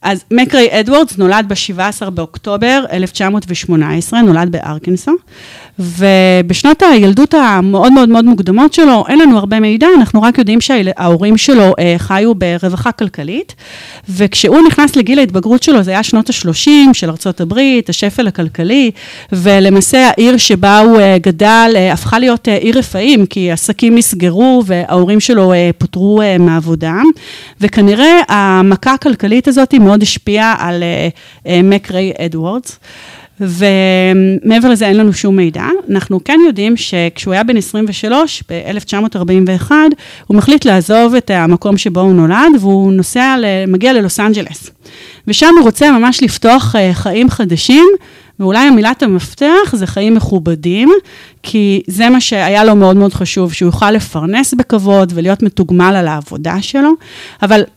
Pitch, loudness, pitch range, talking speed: 205 Hz, -9 LUFS, 185-245 Hz, 135 wpm